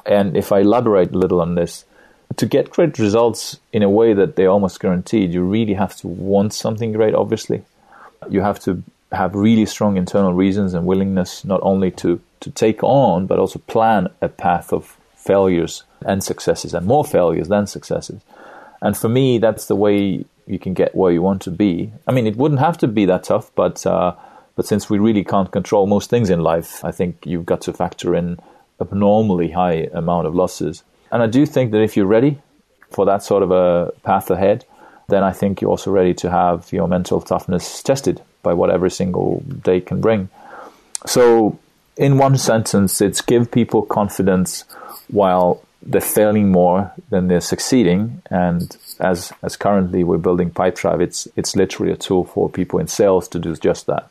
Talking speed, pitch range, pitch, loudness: 195 wpm, 90-110 Hz, 100 Hz, -17 LUFS